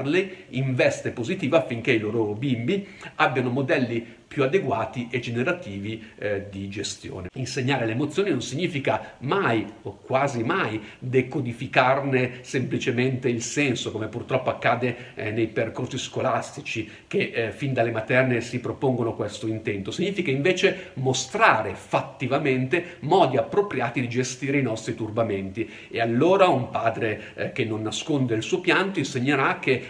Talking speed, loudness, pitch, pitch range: 140 wpm, -25 LUFS, 125 Hz, 115-140 Hz